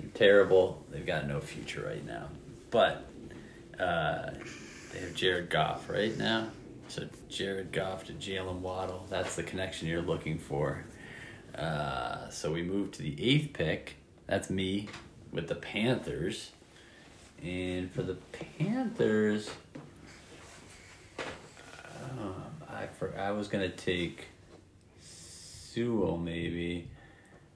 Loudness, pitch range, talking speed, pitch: -33 LUFS, 90-110 Hz, 120 wpm, 95 Hz